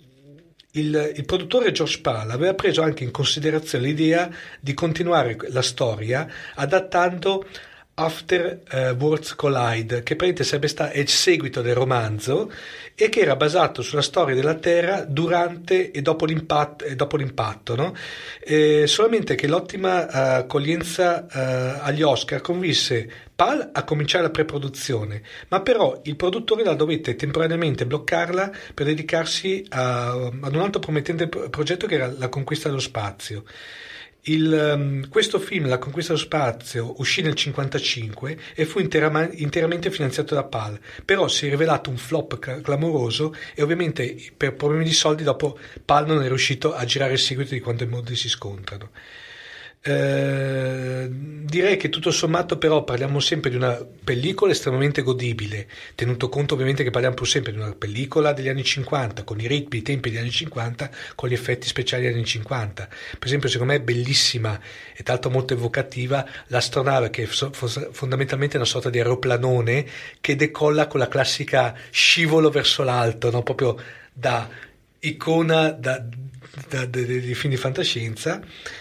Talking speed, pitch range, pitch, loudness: 155 wpm, 125-160 Hz, 145 Hz, -22 LUFS